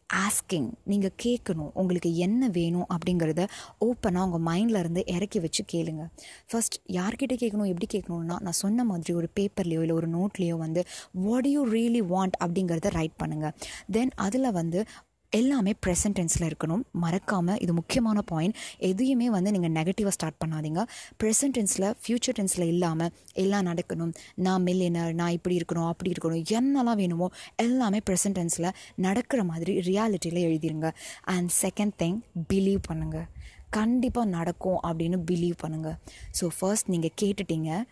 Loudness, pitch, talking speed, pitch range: -28 LUFS, 185 Hz, 140 wpm, 170-215 Hz